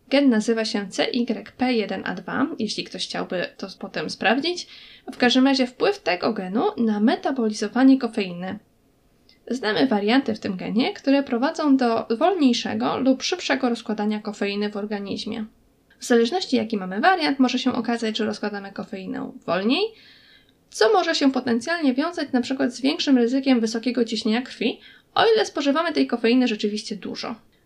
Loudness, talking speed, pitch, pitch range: -22 LUFS, 140 wpm, 240 Hz, 220-270 Hz